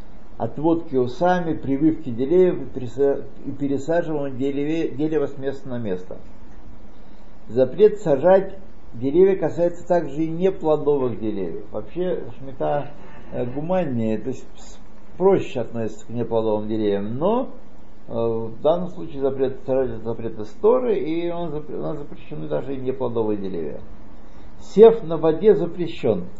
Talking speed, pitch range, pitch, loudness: 115 wpm, 125-170 Hz, 140 Hz, -22 LUFS